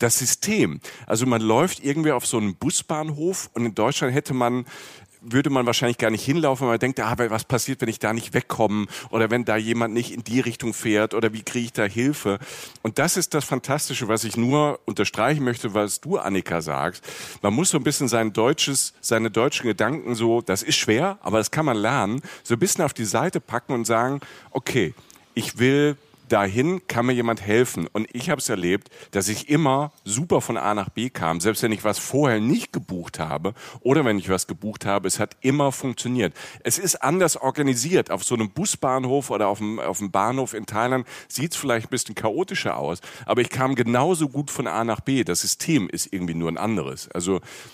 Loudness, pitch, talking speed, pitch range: -23 LUFS, 120 Hz, 215 wpm, 110-135 Hz